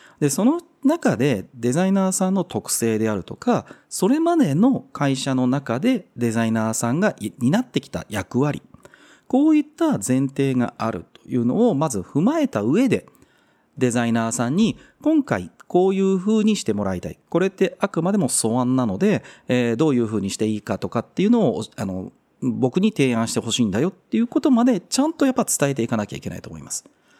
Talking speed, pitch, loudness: 385 characters per minute, 140 Hz, -21 LUFS